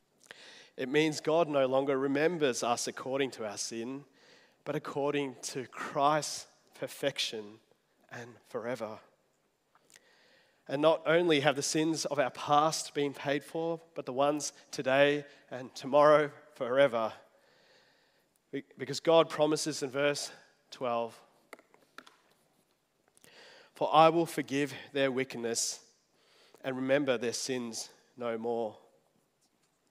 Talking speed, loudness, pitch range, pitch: 110 wpm, -31 LUFS, 130-150 Hz, 140 Hz